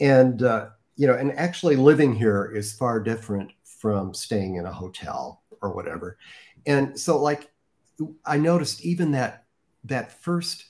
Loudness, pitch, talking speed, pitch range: -24 LUFS, 130 Hz, 150 wpm, 105-150 Hz